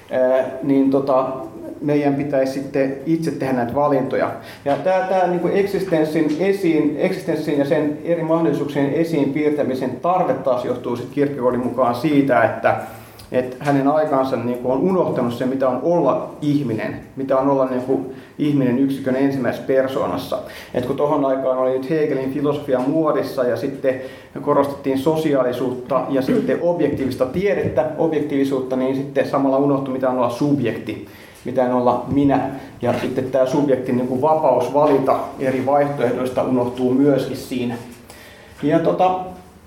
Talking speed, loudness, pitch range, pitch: 135 wpm, -19 LUFS, 130-145 Hz, 135 Hz